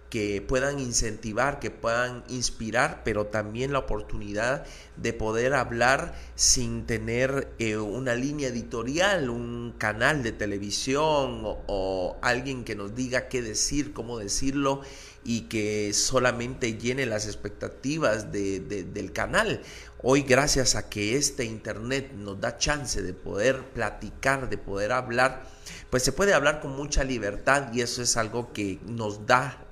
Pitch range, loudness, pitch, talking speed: 105-130 Hz, -27 LUFS, 120 Hz, 145 wpm